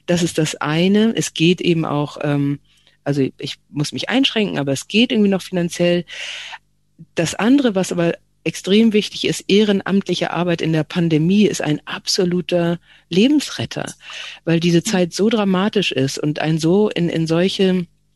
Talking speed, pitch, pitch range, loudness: 155 wpm, 175 Hz, 160-200 Hz, -18 LUFS